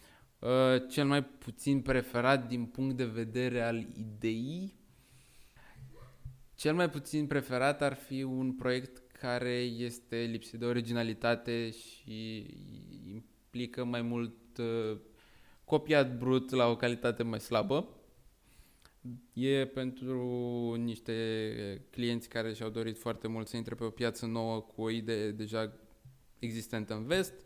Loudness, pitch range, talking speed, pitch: -34 LUFS, 115-130 Hz, 125 wpm, 120 Hz